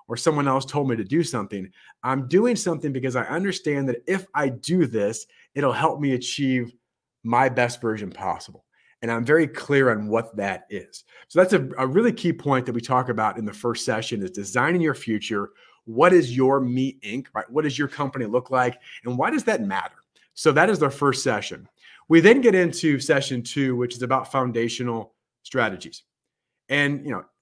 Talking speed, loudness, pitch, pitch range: 200 wpm, -23 LUFS, 130 Hz, 120-150 Hz